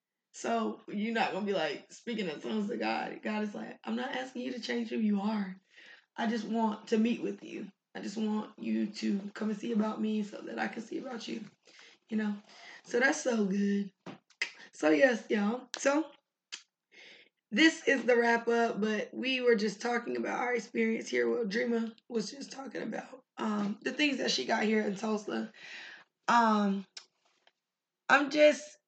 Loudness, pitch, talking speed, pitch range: -32 LUFS, 225 Hz, 185 wpm, 210-250 Hz